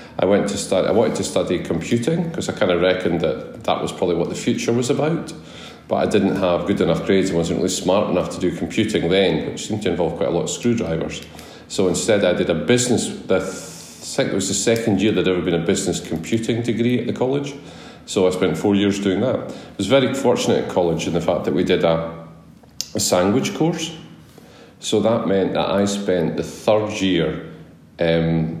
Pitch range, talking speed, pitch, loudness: 85-125 Hz, 220 wpm, 100 Hz, -20 LUFS